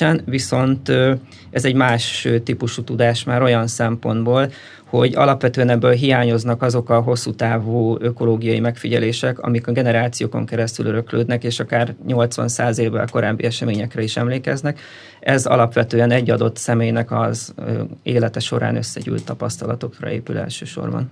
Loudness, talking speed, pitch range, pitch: -19 LUFS, 125 wpm, 115-125 Hz, 120 Hz